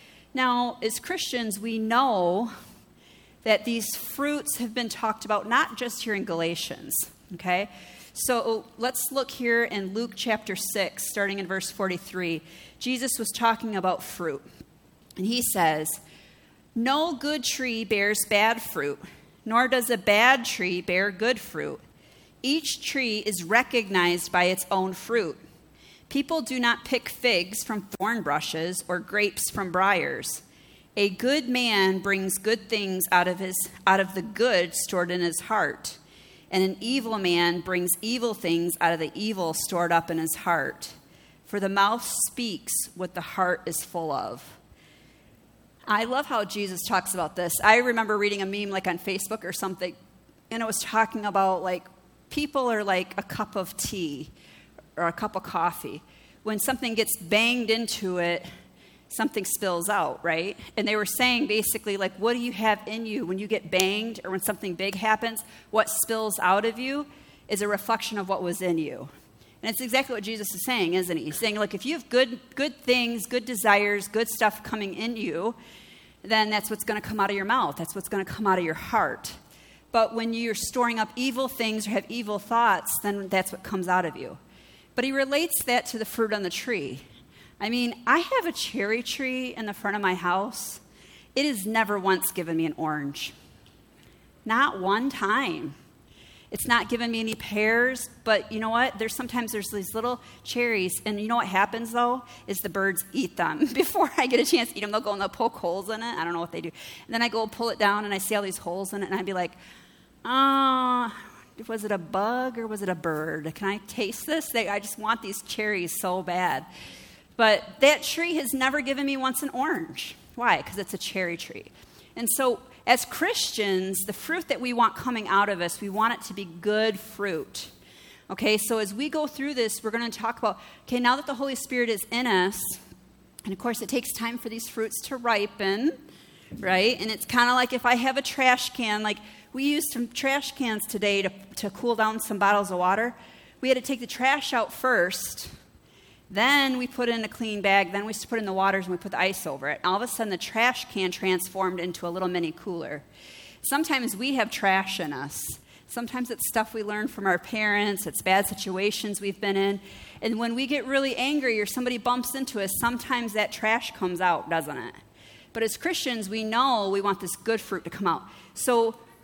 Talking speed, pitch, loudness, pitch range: 205 wpm, 215 Hz, -26 LUFS, 190-240 Hz